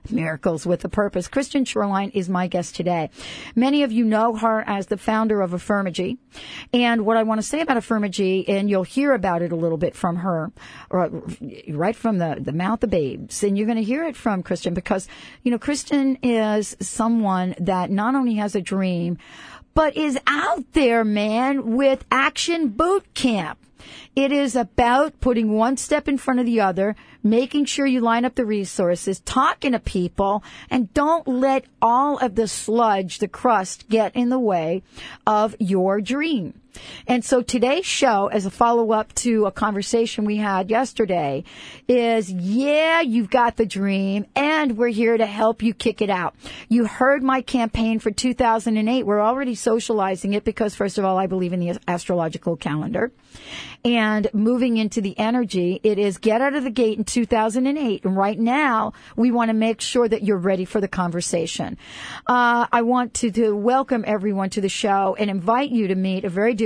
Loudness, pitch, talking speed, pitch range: -21 LUFS, 220 Hz, 185 wpm, 195-245 Hz